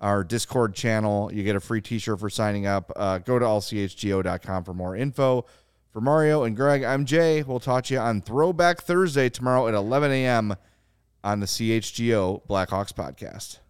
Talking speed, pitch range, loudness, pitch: 180 wpm, 100-130 Hz, -24 LUFS, 115 Hz